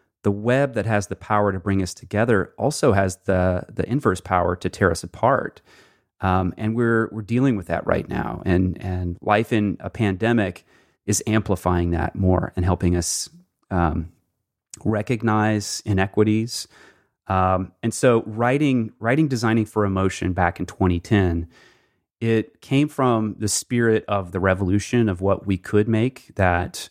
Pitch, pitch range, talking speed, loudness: 100 Hz, 90-115 Hz, 160 wpm, -22 LUFS